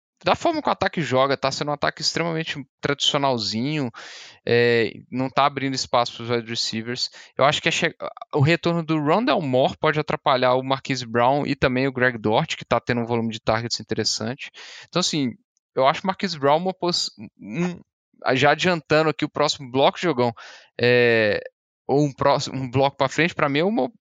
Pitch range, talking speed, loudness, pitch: 125-160 Hz, 190 wpm, -22 LUFS, 140 Hz